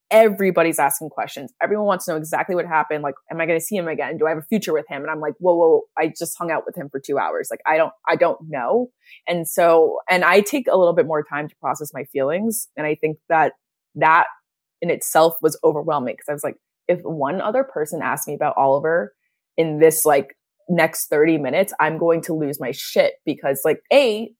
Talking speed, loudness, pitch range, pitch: 235 wpm, -20 LUFS, 155-190 Hz, 165 Hz